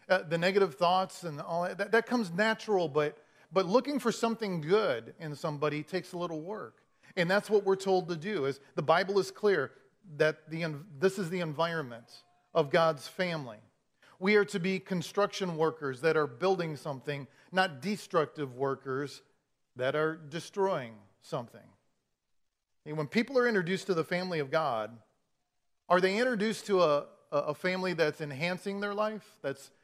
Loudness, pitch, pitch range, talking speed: -31 LUFS, 170 Hz, 150-195 Hz, 165 wpm